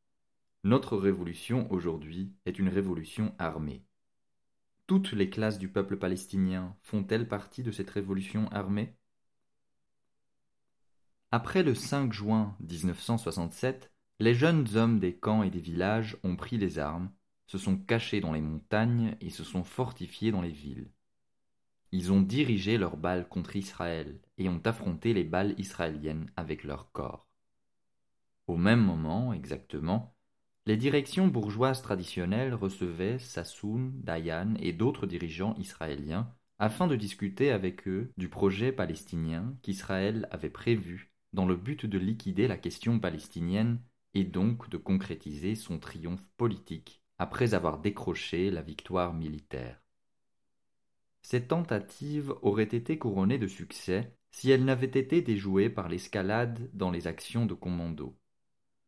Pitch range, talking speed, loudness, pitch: 90-115 Hz, 135 wpm, -32 LUFS, 100 Hz